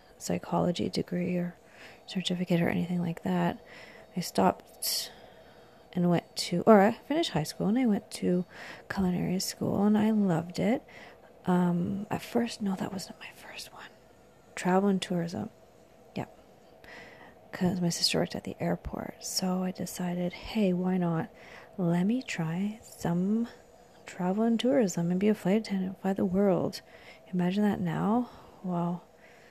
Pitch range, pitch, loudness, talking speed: 175-215 Hz, 185 Hz, -30 LUFS, 150 wpm